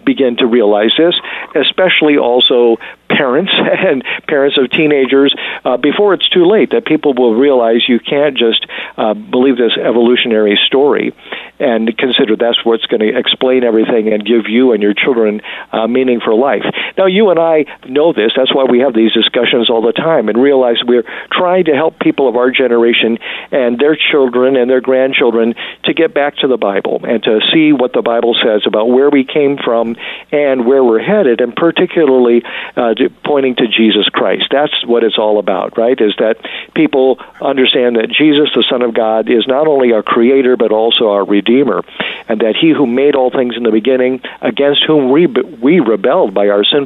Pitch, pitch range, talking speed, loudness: 130 Hz, 115-145 Hz, 190 wpm, -11 LUFS